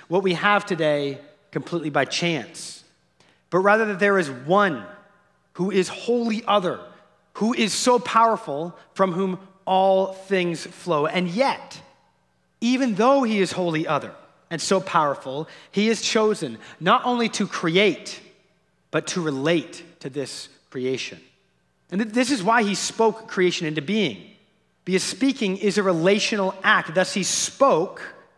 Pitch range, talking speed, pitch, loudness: 170-210 Hz, 145 wpm, 190 Hz, -22 LUFS